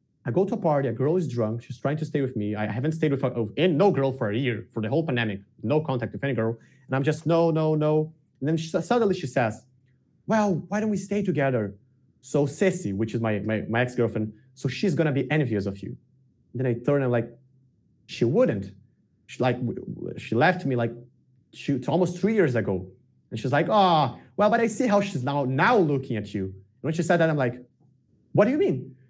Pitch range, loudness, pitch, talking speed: 120-160 Hz, -25 LUFS, 130 Hz, 245 wpm